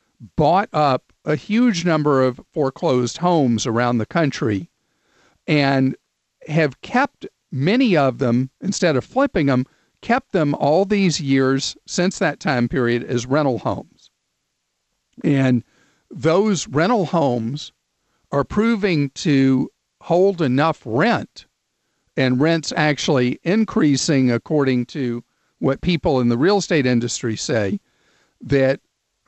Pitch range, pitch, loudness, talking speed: 125-175 Hz, 140 Hz, -19 LUFS, 120 wpm